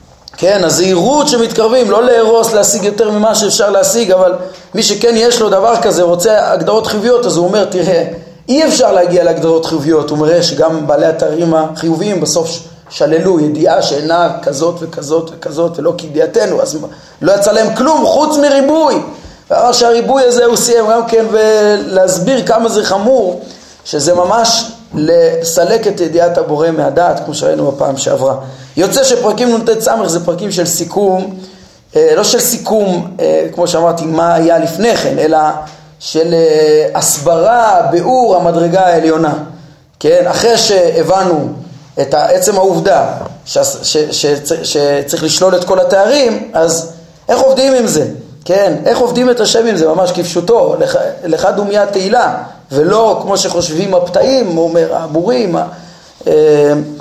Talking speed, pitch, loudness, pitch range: 140 wpm, 185 Hz, -10 LUFS, 165-230 Hz